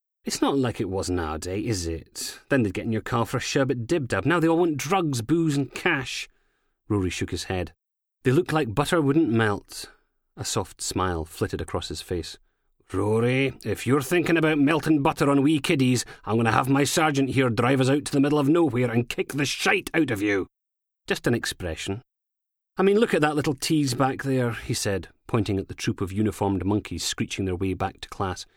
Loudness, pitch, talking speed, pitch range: -24 LUFS, 130 Hz, 220 wpm, 100-150 Hz